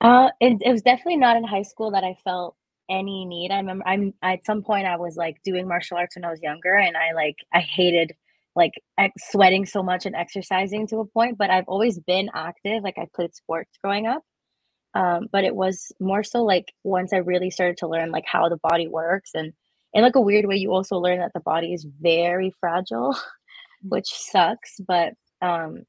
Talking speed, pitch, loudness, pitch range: 215 wpm, 185 Hz, -22 LUFS, 175-200 Hz